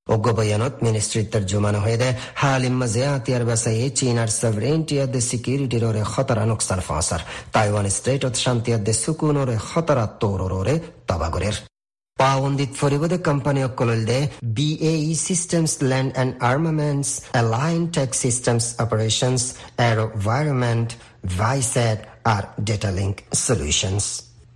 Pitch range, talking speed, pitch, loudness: 110-135 Hz, 125 wpm, 120 Hz, -21 LUFS